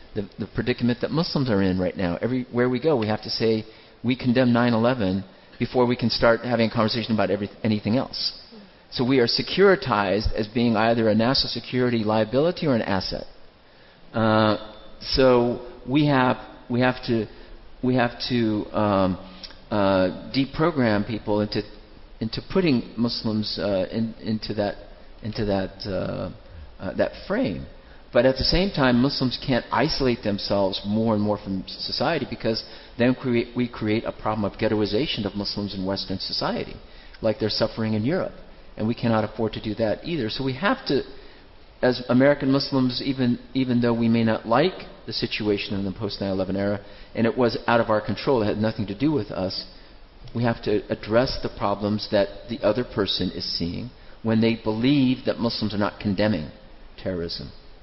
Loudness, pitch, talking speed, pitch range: -24 LUFS, 110 Hz, 175 wpm, 105-125 Hz